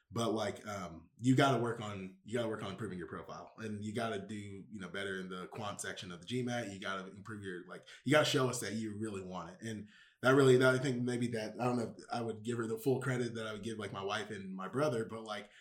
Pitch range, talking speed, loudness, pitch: 100-120 Hz, 300 wpm, -36 LUFS, 110 Hz